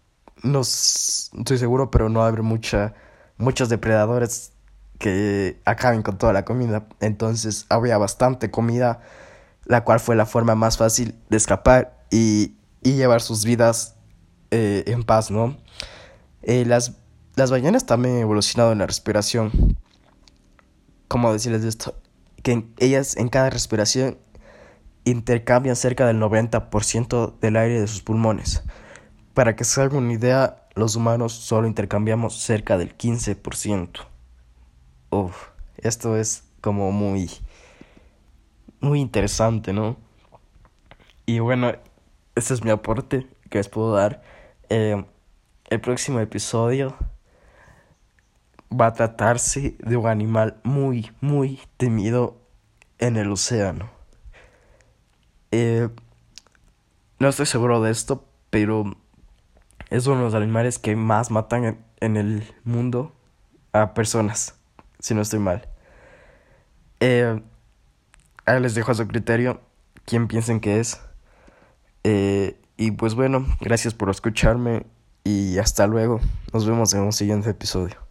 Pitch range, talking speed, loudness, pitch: 105-120 Hz, 125 wpm, -21 LUFS, 115 Hz